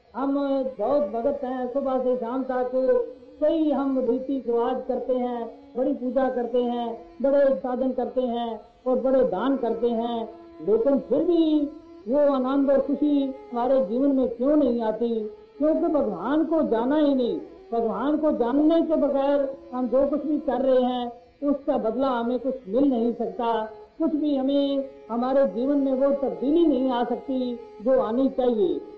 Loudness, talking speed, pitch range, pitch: -24 LUFS, 165 wpm, 240-280 Hz, 260 Hz